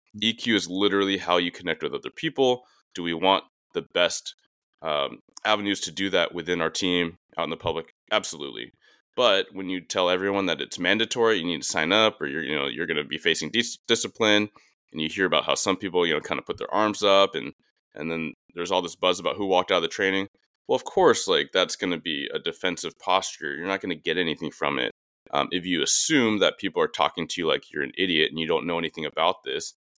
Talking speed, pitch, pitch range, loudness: 240 wpm, 100 Hz, 90-115 Hz, -25 LUFS